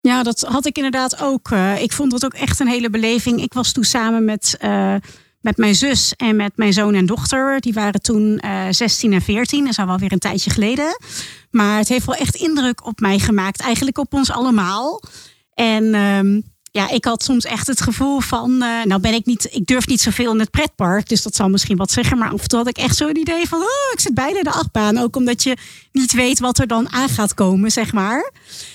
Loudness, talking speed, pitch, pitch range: -17 LUFS, 240 wpm, 230 Hz, 210-255 Hz